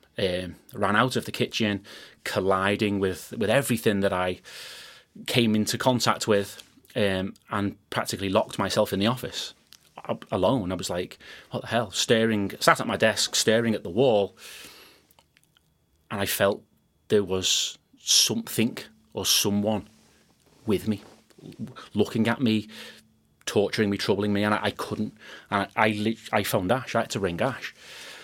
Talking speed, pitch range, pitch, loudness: 155 wpm, 100-115 Hz, 105 Hz, -25 LUFS